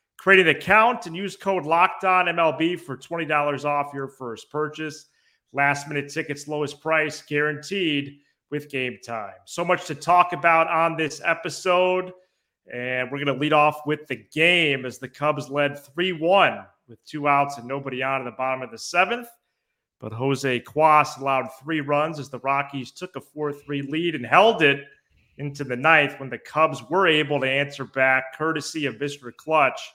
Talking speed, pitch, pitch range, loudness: 175 wpm, 150 Hz, 135-165 Hz, -22 LUFS